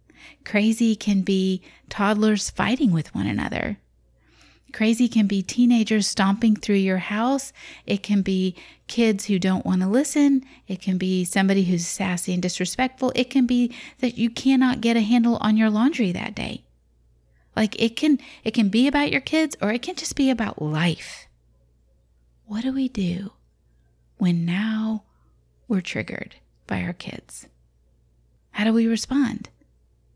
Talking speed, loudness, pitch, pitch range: 155 wpm, -22 LUFS, 205 Hz, 170-235 Hz